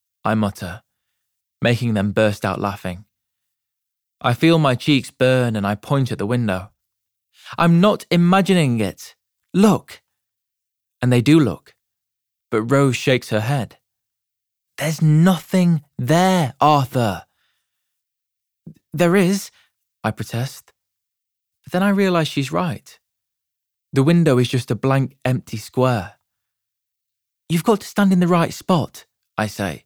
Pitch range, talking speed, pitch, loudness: 105-155 Hz, 130 wpm, 120 Hz, -18 LUFS